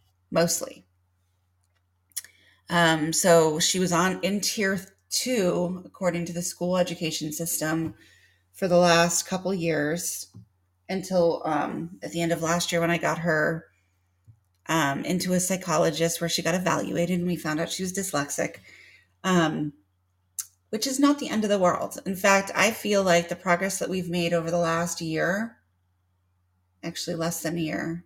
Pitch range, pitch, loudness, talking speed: 115-180 Hz, 170 Hz, -25 LUFS, 160 wpm